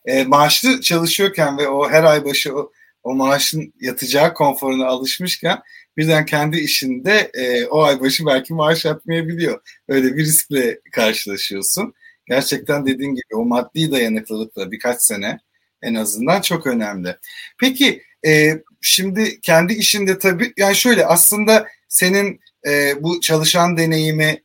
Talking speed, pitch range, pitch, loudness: 135 wpm, 135-190 Hz, 155 Hz, -16 LUFS